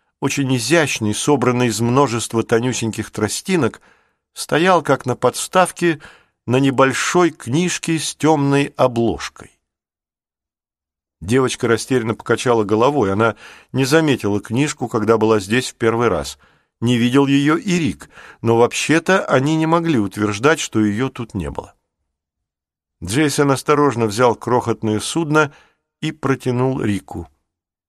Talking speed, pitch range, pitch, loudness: 120 wpm, 105-145 Hz, 125 Hz, -17 LUFS